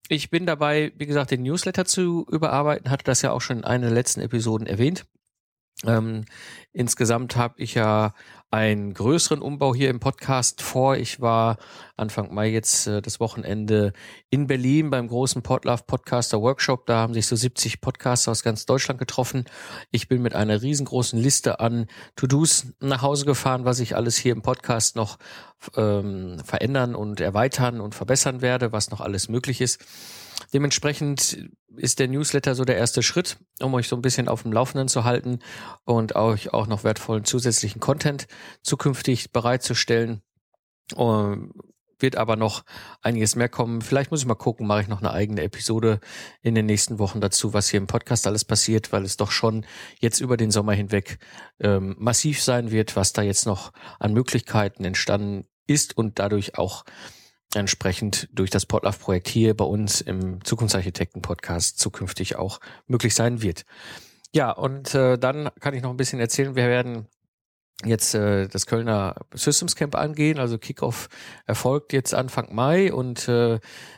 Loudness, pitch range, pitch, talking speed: -23 LUFS, 105-130 Hz, 120 Hz, 170 wpm